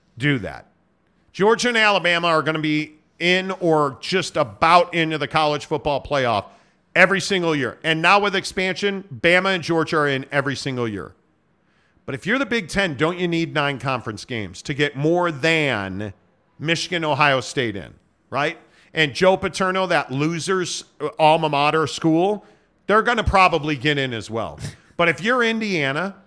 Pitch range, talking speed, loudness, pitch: 145-185 Hz, 170 wpm, -20 LUFS, 160 Hz